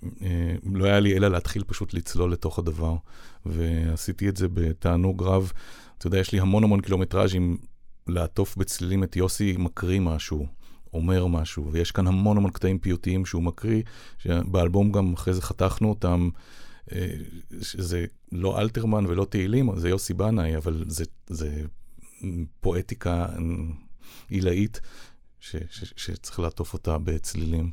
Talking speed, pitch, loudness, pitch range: 130 wpm, 90 Hz, -26 LUFS, 85-95 Hz